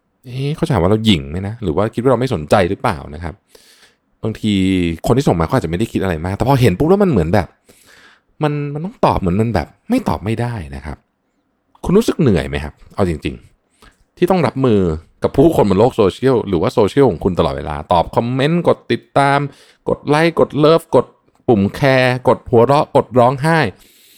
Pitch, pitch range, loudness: 115 Hz, 95-140 Hz, -15 LUFS